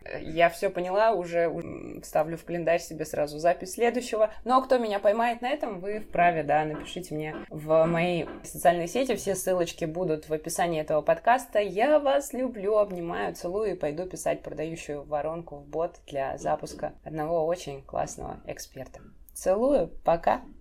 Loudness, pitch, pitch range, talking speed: -27 LUFS, 170 Hz, 155-210 Hz, 155 wpm